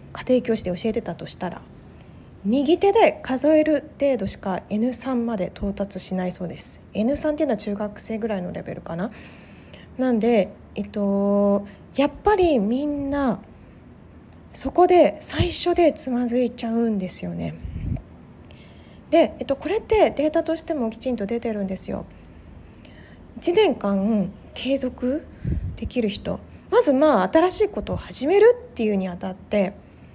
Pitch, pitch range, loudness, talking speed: 240 Hz, 200-300 Hz, -22 LUFS, 260 characters per minute